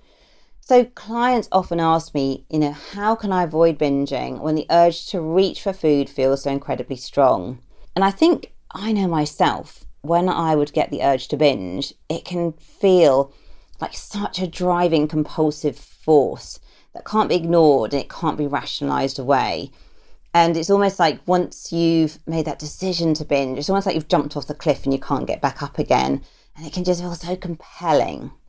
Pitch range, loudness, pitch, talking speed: 145-180 Hz, -20 LUFS, 165 Hz, 185 wpm